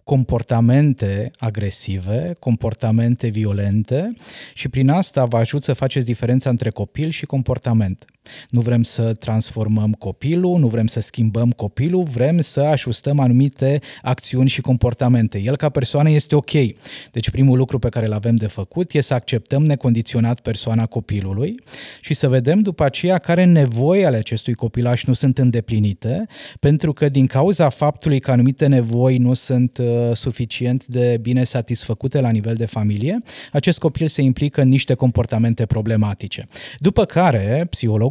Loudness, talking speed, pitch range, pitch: -18 LUFS, 150 wpm, 115-145 Hz, 125 Hz